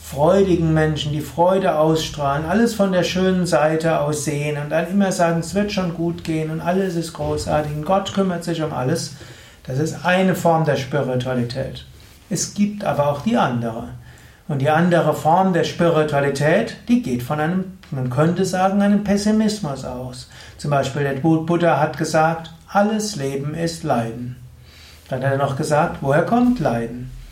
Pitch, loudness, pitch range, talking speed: 160 Hz, -19 LUFS, 140-180 Hz, 165 wpm